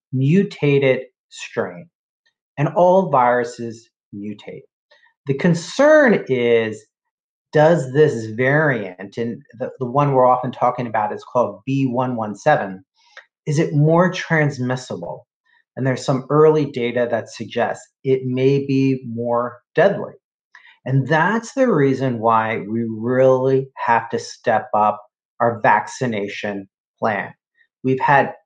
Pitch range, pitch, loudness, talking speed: 120-155 Hz, 130 Hz, -18 LUFS, 115 wpm